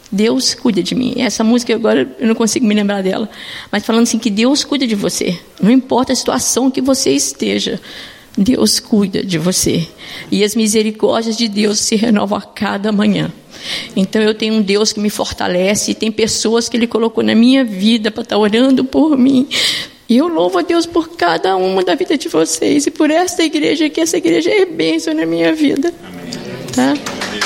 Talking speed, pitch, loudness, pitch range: 195 wpm, 230 Hz, -14 LUFS, 210-265 Hz